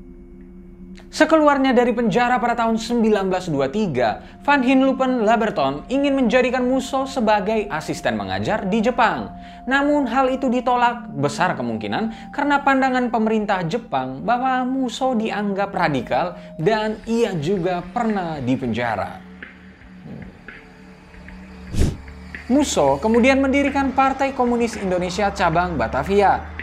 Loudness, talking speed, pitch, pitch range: -20 LUFS, 100 wpm, 220 Hz, 175-255 Hz